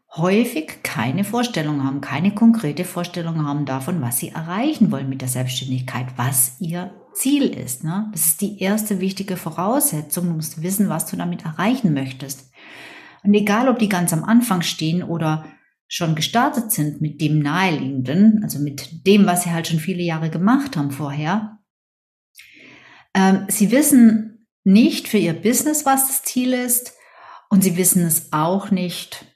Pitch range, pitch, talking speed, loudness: 155-215 Hz, 180 Hz, 160 wpm, -19 LUFS